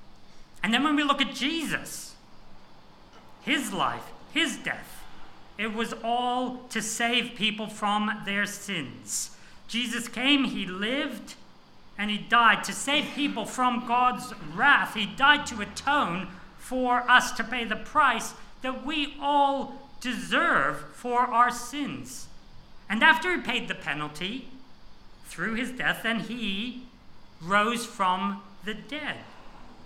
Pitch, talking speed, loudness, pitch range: 240 Hz, 130 wpm, -26 LUFS, 210-260 Hz